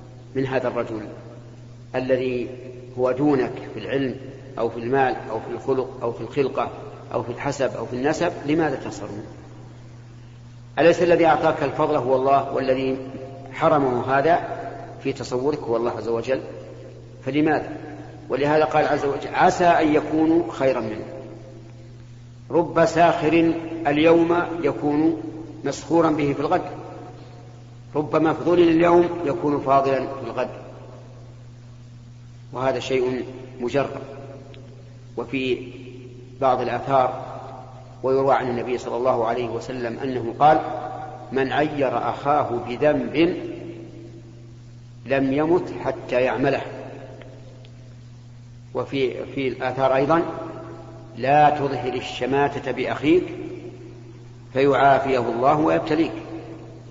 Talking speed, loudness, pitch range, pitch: 105 wpm, -22 LUFS, 120-145 Hz, 130 Hz